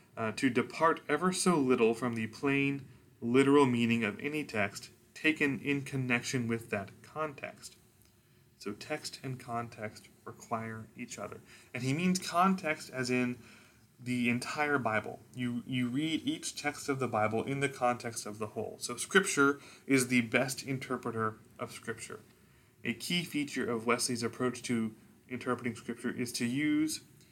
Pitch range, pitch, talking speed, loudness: 115-140 Hz, 125 Hz, 155 wpm, -32 LUFS